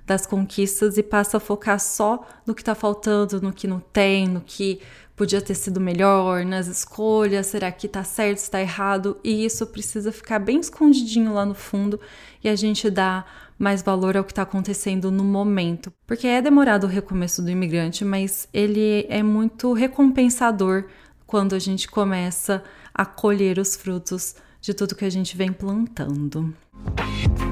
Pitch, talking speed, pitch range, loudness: 200 Hz, 170 wpm, 190-215 Hz, -22 LUFS